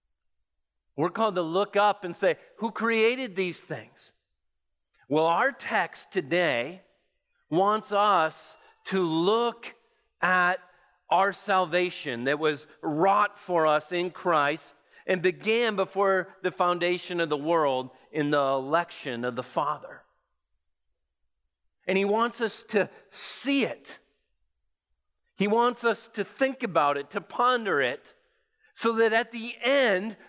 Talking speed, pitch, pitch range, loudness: 130 wpm, 180 Hz, 145-220 Hz, -26 LUFS